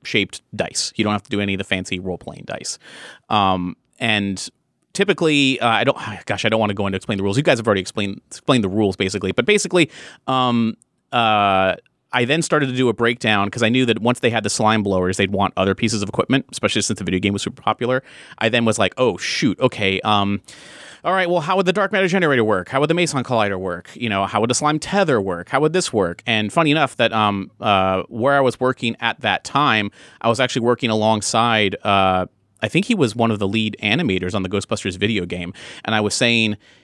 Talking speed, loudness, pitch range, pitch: 240 wpm, -19 LUFS, 100-130 Hz, 110 Hz